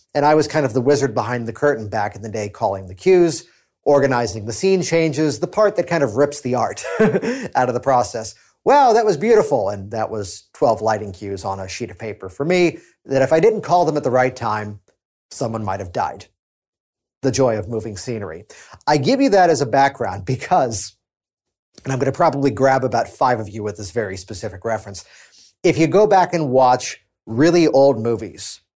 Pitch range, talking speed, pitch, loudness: 105-155 Hz, 210 wpm, 125 Hz, -18 LUFS